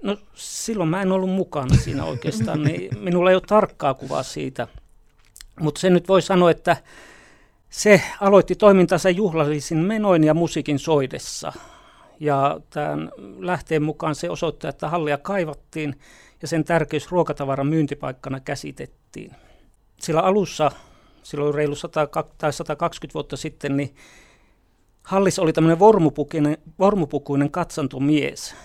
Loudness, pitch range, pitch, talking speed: -21 LUFS, 145-180 Hz, 155 Hz, 120 wpm